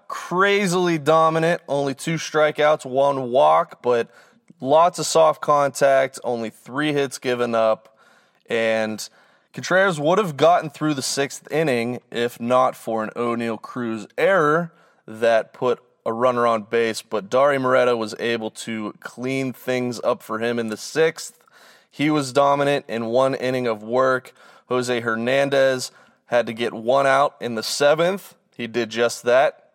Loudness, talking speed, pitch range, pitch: -21 LUFS, 150 wpm, 115-145 Hz, 130 Hz